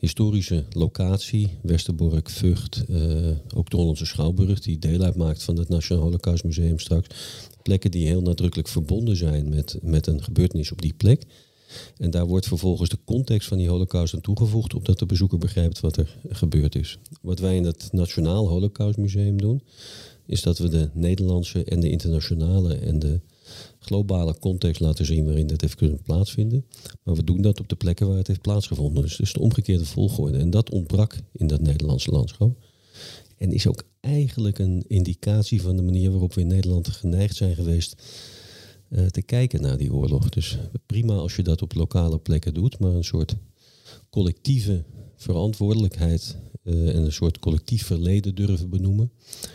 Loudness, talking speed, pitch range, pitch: -23 LUFS, 175 wpm, 85-110 Hz, 95 Hz